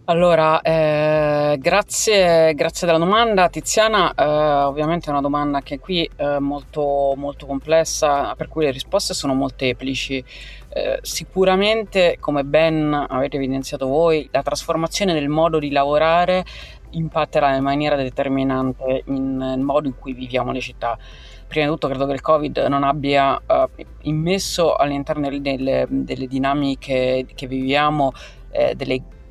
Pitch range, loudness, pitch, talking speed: 135-160 Hz, -19 LUFS, 145 Hz, 140 wpm